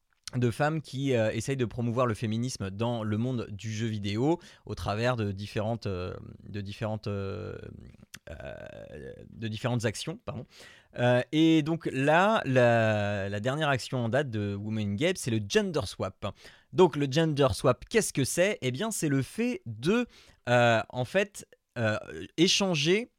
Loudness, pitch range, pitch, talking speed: -28 LUFS, 110-150 Hz, 120 Hz, 160 wpm